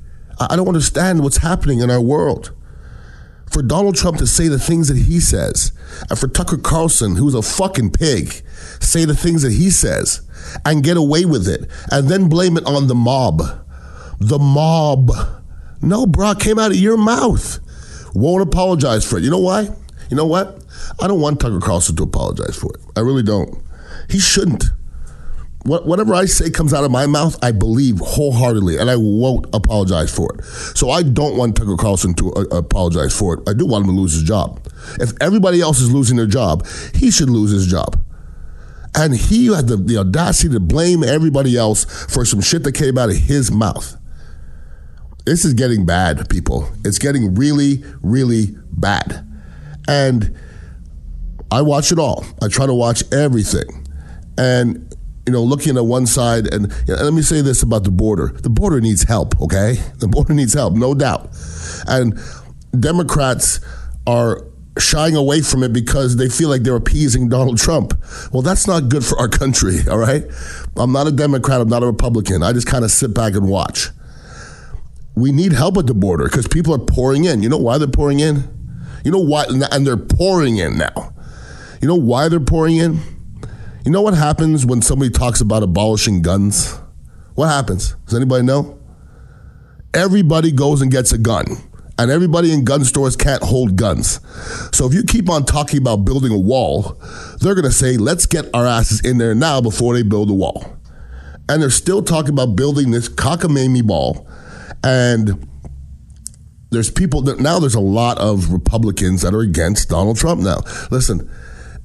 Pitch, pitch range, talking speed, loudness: 120 Hz, 90-145 Hz, 185 wpm, -15 LUFS